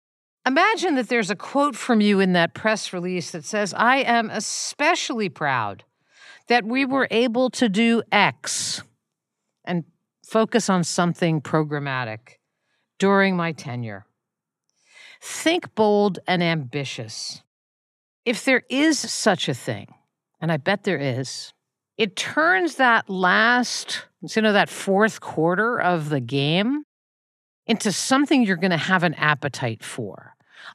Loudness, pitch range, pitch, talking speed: -21 LUFS, 160-245 Hz, 195 Hz, 135 wpm